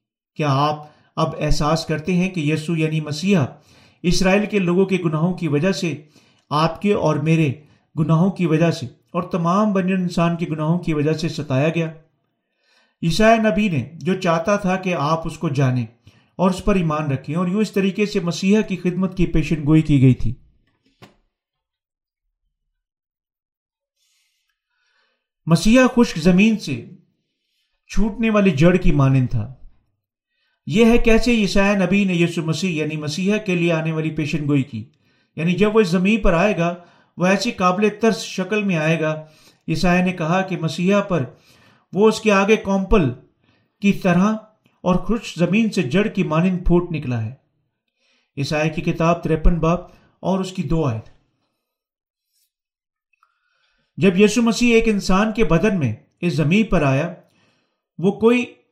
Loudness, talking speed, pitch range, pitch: -19 LUFS, 160 wpm, 155-200 Hz, 175 Hz